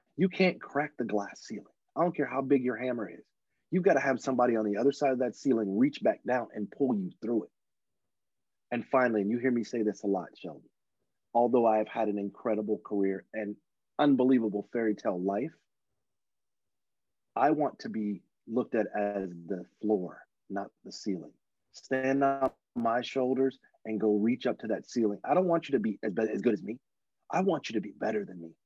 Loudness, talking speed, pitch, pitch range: -30 LUFS, 205 wpm, 120 Hz, 105-135 Hz